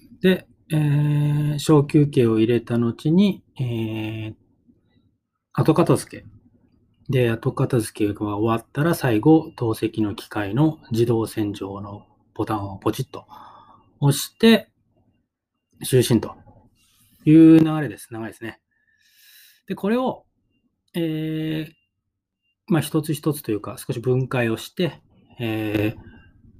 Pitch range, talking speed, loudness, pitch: 110-155 Hz, 210 characters per minute, -21 LUFS, 120 Hz